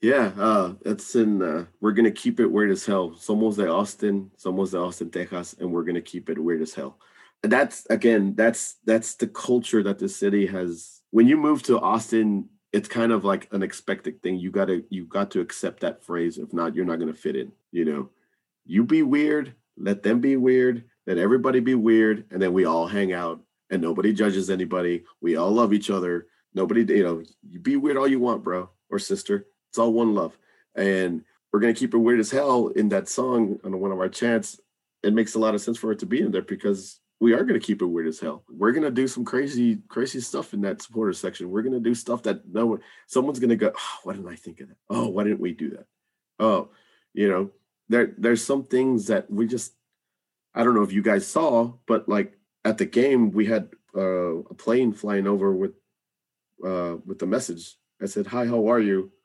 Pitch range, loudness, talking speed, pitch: 95-120 Hz, -24 LUFS, 225 wpm, 110 Hz